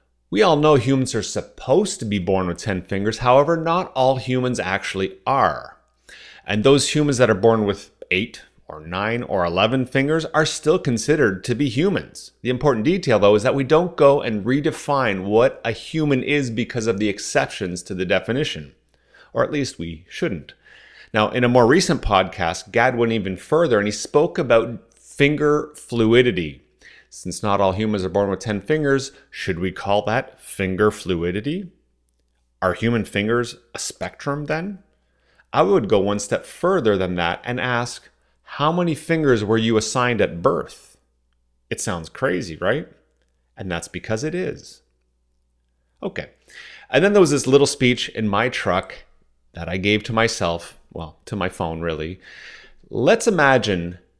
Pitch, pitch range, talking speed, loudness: 110 Hz, 90-135 Hz, 165 wpm, -20 LUFS